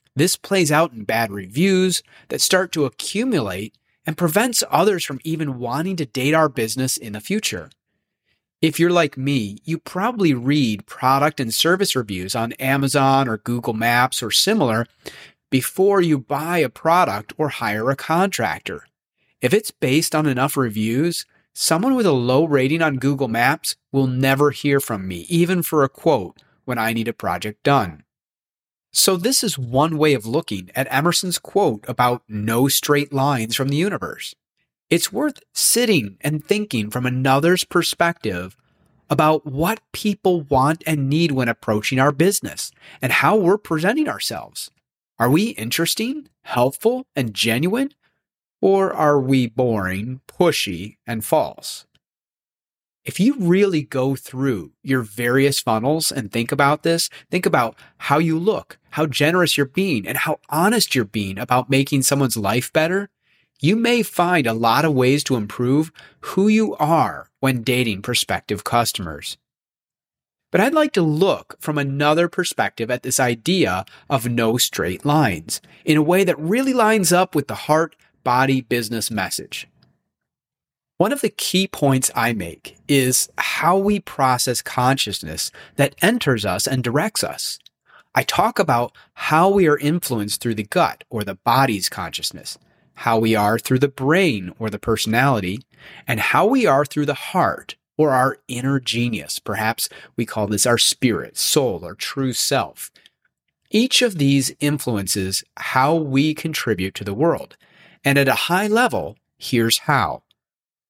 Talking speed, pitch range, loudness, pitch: 155 wpm, 120-170 Hz, -19 LUFS, 140 Hz